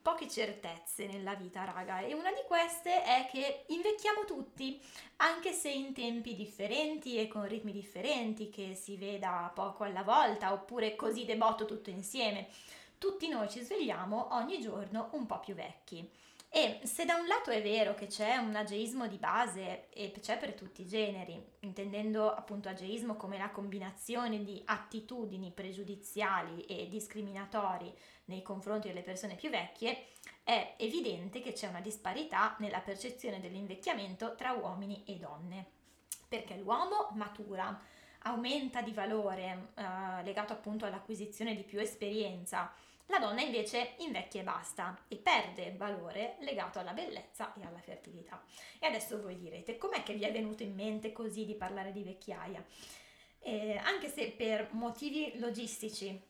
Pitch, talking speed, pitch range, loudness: 215 Hz, 150 wpm, 200-240 Hz, -38 LUFS